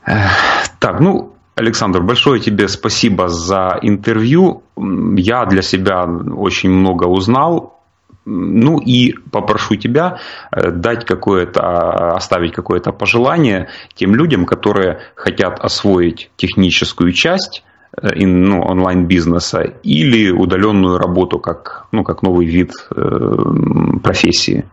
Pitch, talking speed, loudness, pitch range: 95 Hz, 105 wpm, -13 LUFS, 90-105 Hz